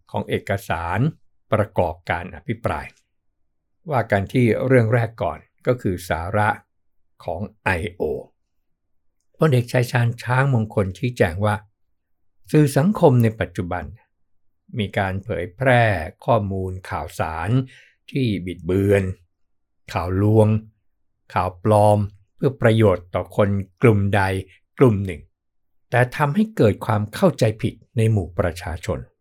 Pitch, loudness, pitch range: 100 Hz, -21 LUFS, 90-115 Hz